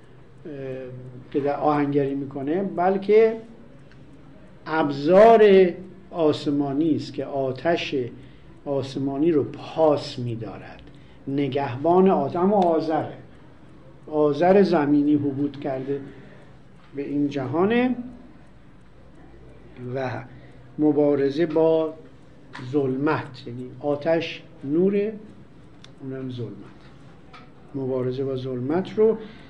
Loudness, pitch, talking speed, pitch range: -22 LUFS, 145 Hz, 75 wpm, 135-170 Hz